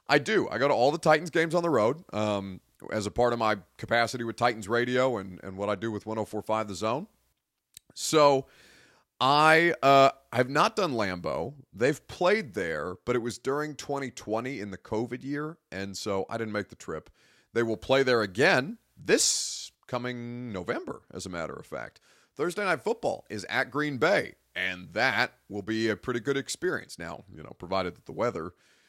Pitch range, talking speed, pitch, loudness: 105-135 Hz, 190 wpm, 120 Hz, -28 LUFS